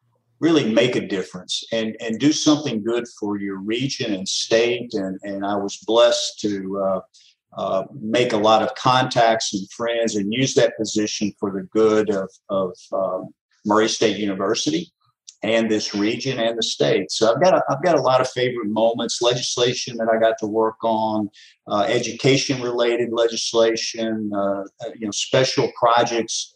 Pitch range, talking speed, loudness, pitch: 105-120 Hz, 170 wpm, -20 LUFS, 115 Hz